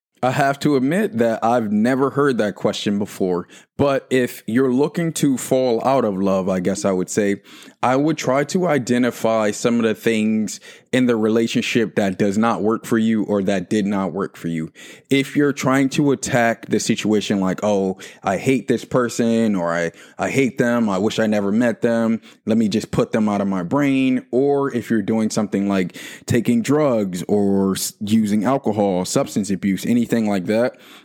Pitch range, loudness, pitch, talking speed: 100-130 Hz, -19 LUFS, 115 Hz, 190 wpm